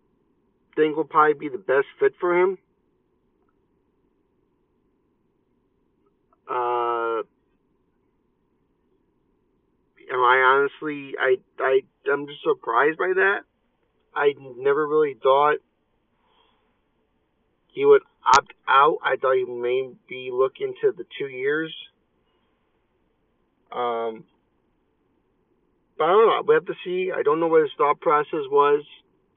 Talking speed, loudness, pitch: 110 wpm, -22 LUFS, 365 Hz